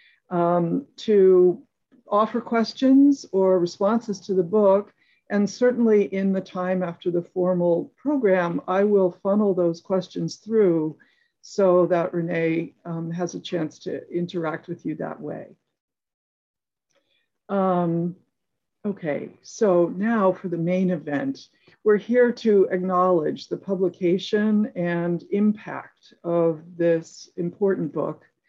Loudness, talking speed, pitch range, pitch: -23 LUFS, 120 wpm, 175-205 Hz, 185 Hz